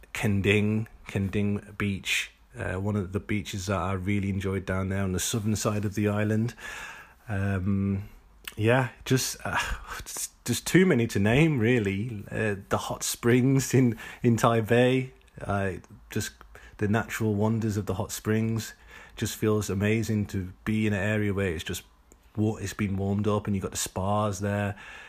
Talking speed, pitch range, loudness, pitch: 165 wpm, 100-115 Hz, -27 LUFS, 105 Hz